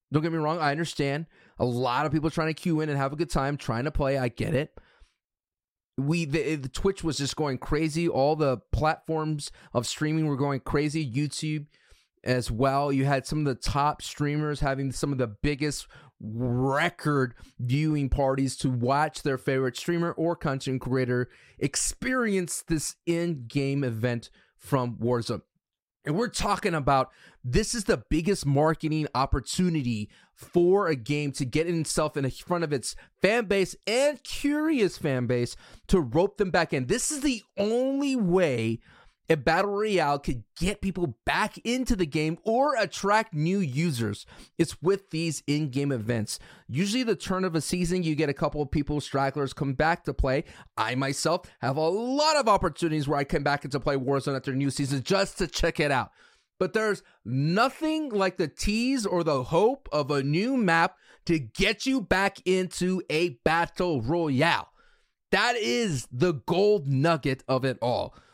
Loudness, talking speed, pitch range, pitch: -27 LUFS, 175 wpm, 135-180 Hz, 155 Hz